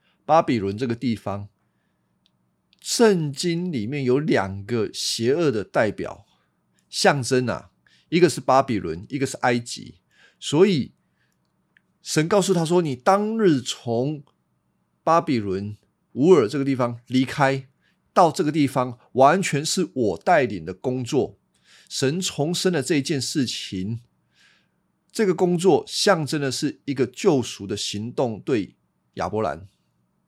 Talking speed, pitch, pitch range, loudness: 190 characters per minute, 130 Hz, 105-155 Hz, -22 LUFS